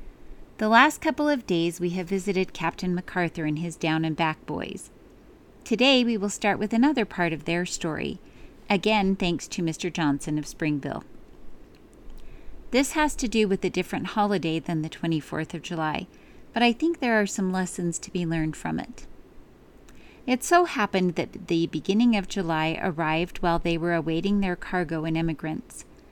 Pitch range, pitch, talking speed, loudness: 165-210 Hz, 180 Hz, 170 wpm, -26 LUFS